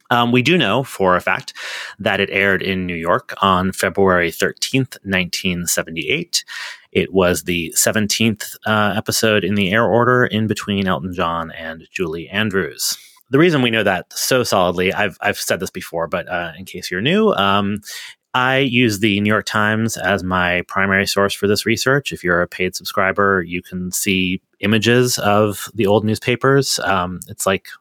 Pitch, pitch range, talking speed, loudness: 100 Hz, 90-110 Hz, 175 wpm, -17 LUFS